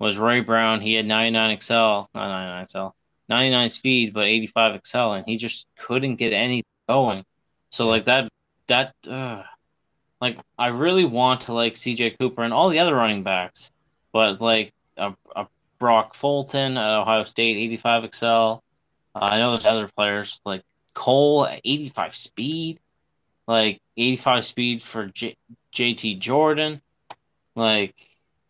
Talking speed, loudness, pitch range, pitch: 150 wpm, -21 LUFS, 110-125 Hz, 115 Hz